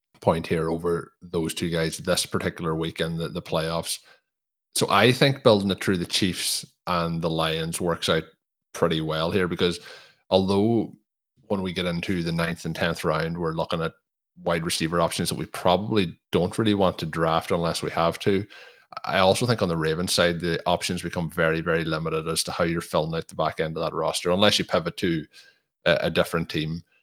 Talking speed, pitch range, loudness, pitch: 200 wpm, 80-95 Hz, -25 LUFS, 85 Hz